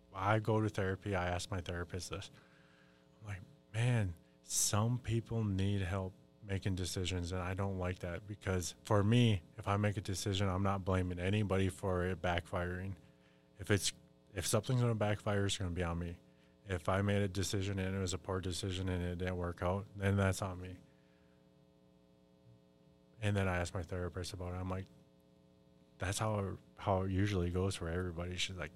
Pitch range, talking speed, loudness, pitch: 85-100 Hz, 190 wpm, -37 LUFS, 95 Hz